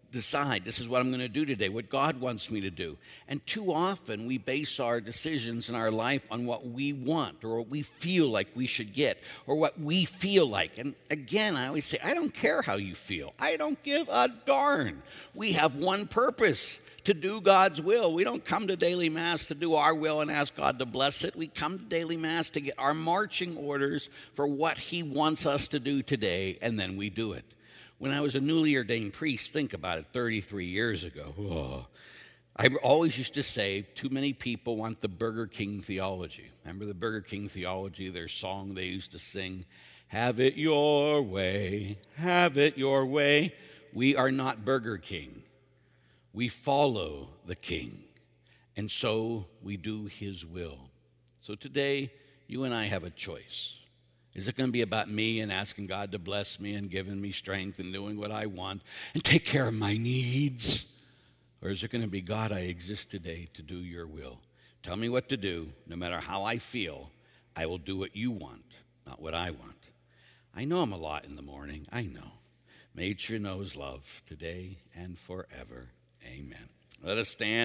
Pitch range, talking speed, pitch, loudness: 95-145 Hz, 200 wpm, 115 Hz, -30 LUFS